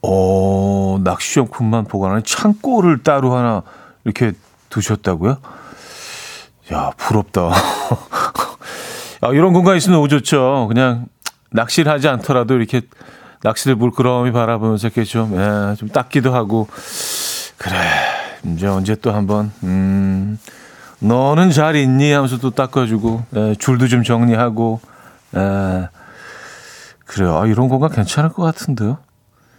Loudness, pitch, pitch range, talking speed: -16 LUFS, 115 Hz, 105-130 Hz, 250 characters per minute